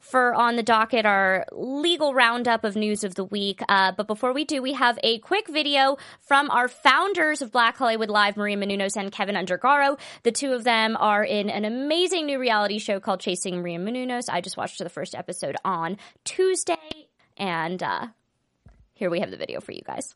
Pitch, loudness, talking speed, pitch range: 230 Hz, -23 LUFS, 200 wpm, 205-275 Hz